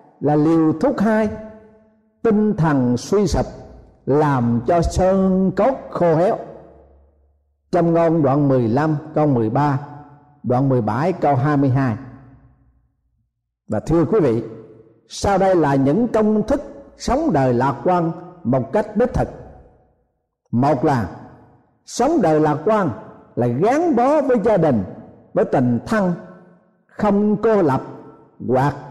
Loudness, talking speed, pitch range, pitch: -18 LUFS, 125 wpm, 130-205 Hz, 155 Hz